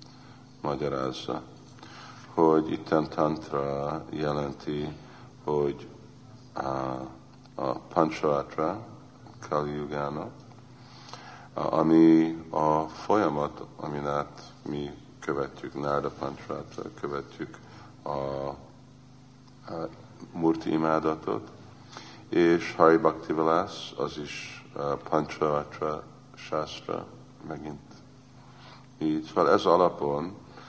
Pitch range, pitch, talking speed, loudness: 70-85 Hz, 80 Hz, 65 wpm, -28 LUFS